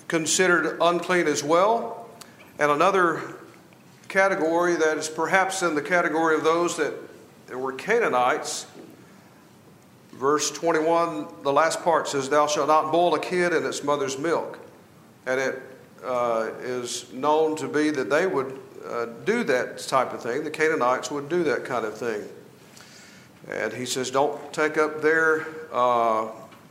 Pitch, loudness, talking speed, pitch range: 155 Hz, -24 LUFS, 150 wpm, 140-170 Hz